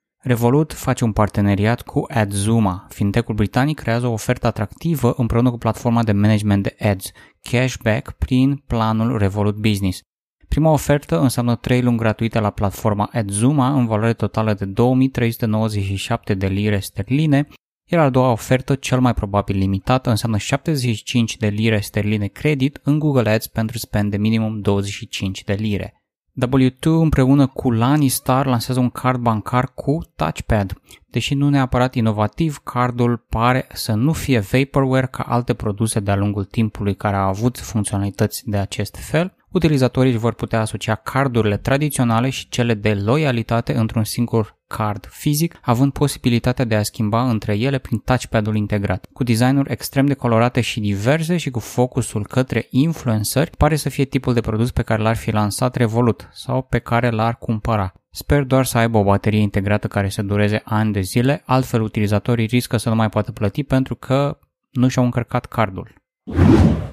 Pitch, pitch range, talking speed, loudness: 115 Hz, 105-130 Hz, 160 wpm, -19 LUFS